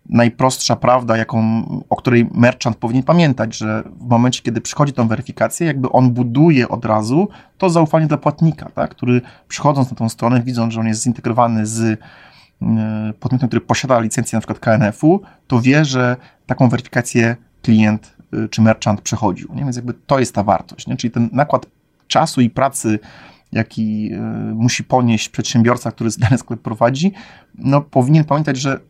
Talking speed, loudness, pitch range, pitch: 160 wpm, -16 LUFS, 115-135 Hz, 120 Hz